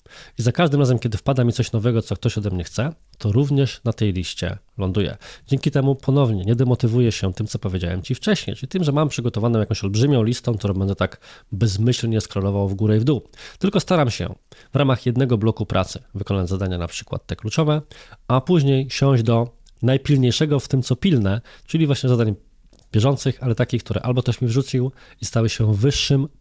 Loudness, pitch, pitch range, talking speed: -21 LUFS, 120 Hz, 105-135 Hz, 200 wpm